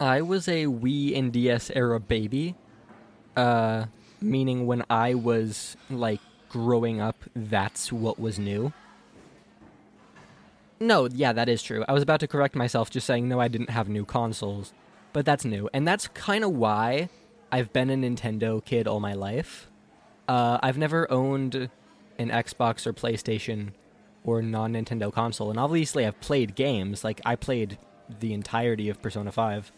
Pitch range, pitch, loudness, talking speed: 110-130 Hz, 115 Hz, -27 LUFS, 160 wpm